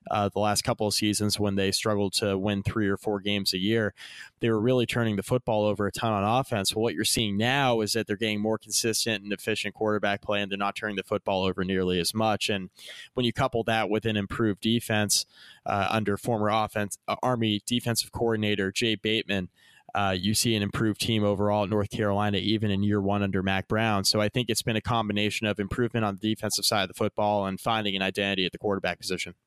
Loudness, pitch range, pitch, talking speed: -27 LUFS, 100-110 Hz, 105 Hz, 230 wpm